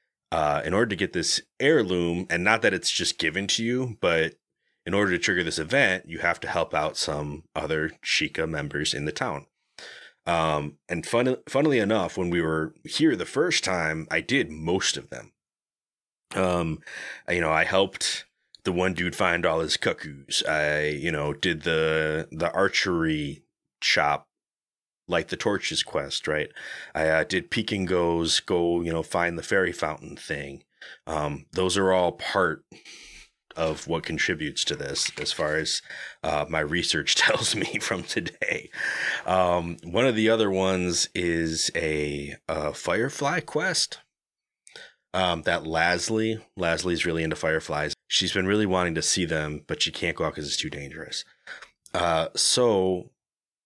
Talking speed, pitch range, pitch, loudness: 160 wpm, 80-95 Hz, 85 Hz, -25 LUFS